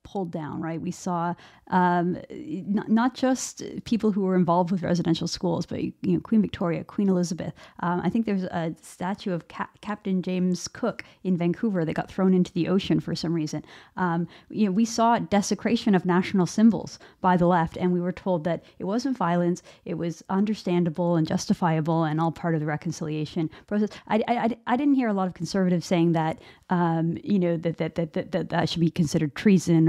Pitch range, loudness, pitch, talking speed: 170-200 Hz, -25 LUFS, 180 Hz, 205 wpm